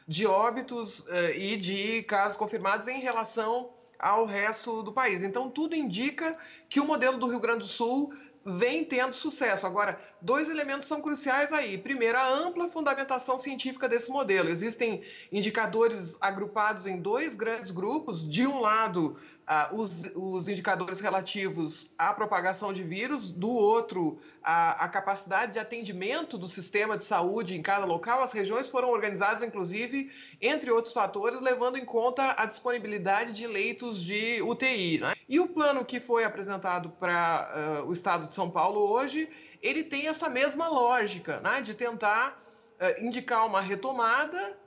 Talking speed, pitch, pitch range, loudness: 155 wpm, 230 Hz, 195-260 Hz, -29 LUFS